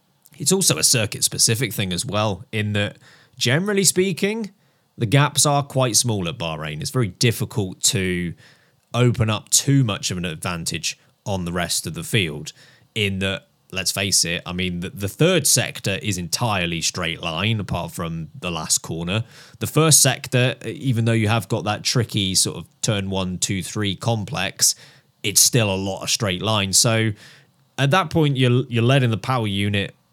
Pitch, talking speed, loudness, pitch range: 115 Hz, 175 wpm, -20 LUFS, 100-140 Hz